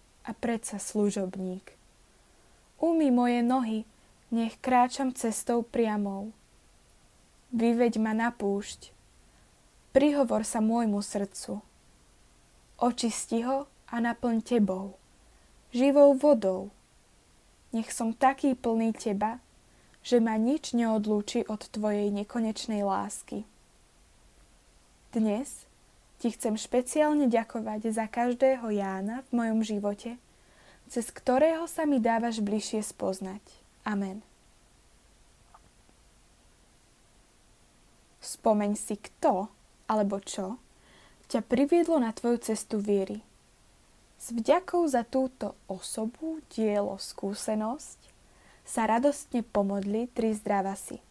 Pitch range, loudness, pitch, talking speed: 205-245 Hz, -29 LUFS, 225 Hz, 95 wpm